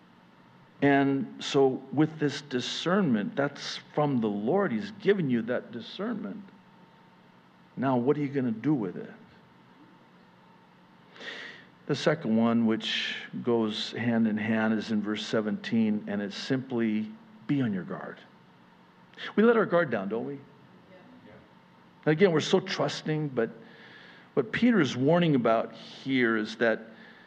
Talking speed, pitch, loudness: 140 wpm, 140 Hz, -28 LUFS